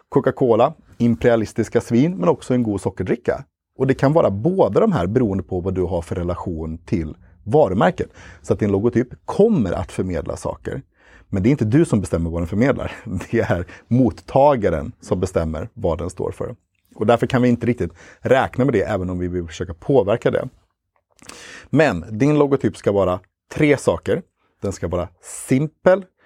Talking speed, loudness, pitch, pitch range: 180 wpm, -20 LUFS, 110 Hz, 90-125 Hz